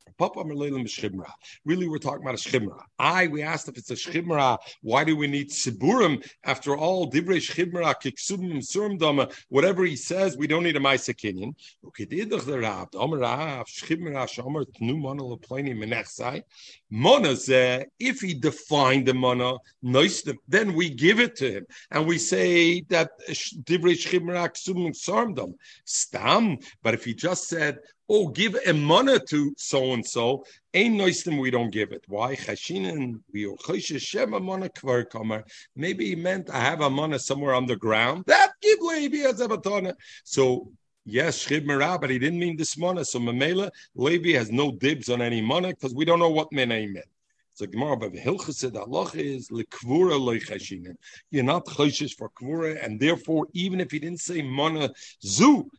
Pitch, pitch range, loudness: 150 Hz, 130-175 Hz, -25 LUFS